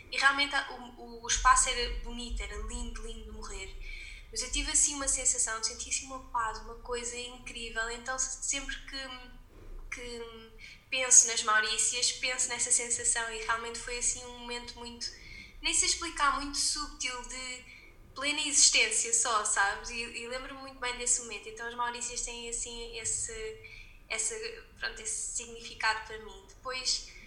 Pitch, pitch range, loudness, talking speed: 245 Hz, 230-260 Hz, -29 LUFS, 160 wpm